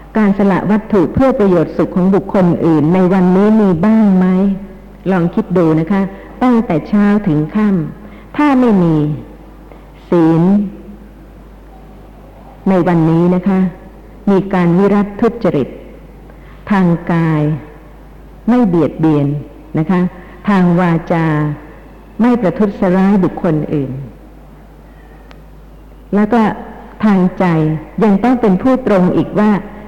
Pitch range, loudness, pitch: 165-205 Hz, -13 LUFS, 185 Hz